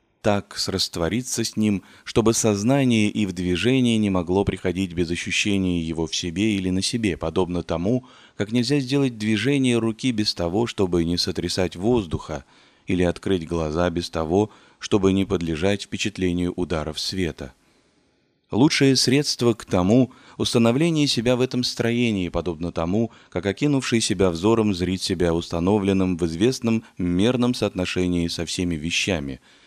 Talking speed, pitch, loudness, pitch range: 140 wpm, 100 Hz, -22 LUFS, 90-115 Hz